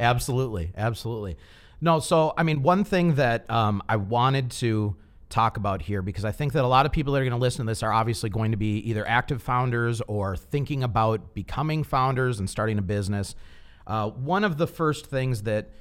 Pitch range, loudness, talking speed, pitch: 105-135 Hz, -25 LUFS, 210 wpm, 115 Hz